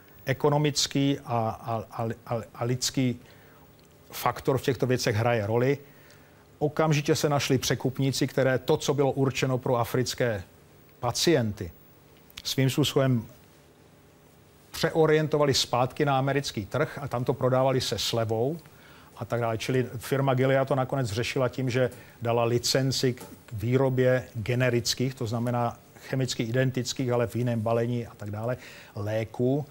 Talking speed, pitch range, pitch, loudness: 135 wpm, 120-140 Hz, 125 Hz, -27 LUFS